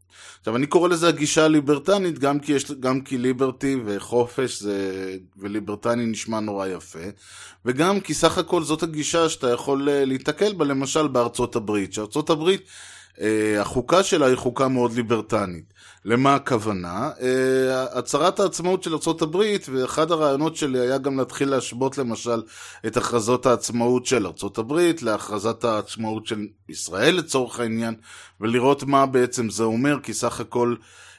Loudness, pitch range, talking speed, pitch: -22 LUFS, 115-150 Hz, 135 wpm, 130 Hz